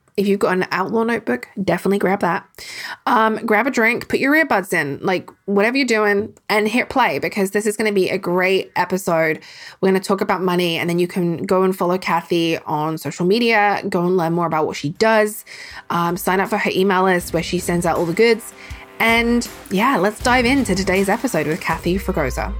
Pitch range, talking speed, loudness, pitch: 175-210 Hz, 220 wpm, -18 LUFS, 190 Hz